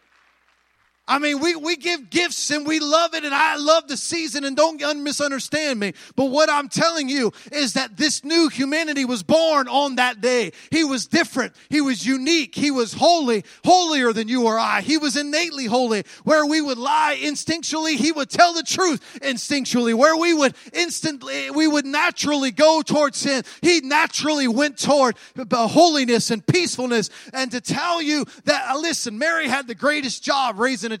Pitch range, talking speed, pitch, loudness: 255-315 Hz, 180 wpm, 290 Hz, -20 LUFS